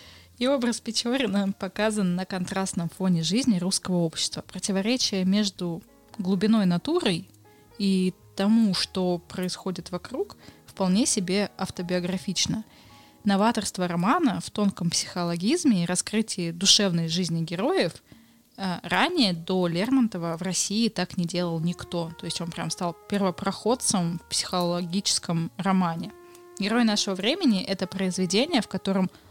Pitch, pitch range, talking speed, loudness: 190 Hz, 175-215 Hz, 115 wpm, -25 LUFS